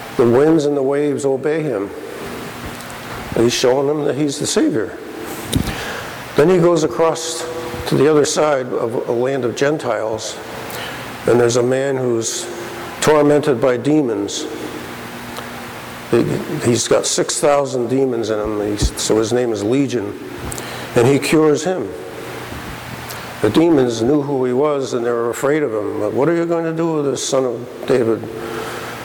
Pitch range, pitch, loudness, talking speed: 120-150 Hz, 135 Hz, -17 LUFS, 155 wpm